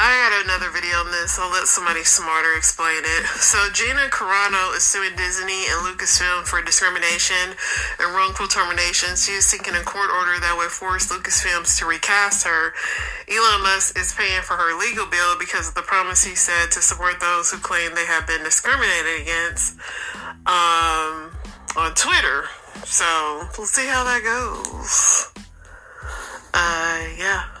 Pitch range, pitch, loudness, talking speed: 170-200 Hz, 180 Hz, -18 LUFS, 160 wpm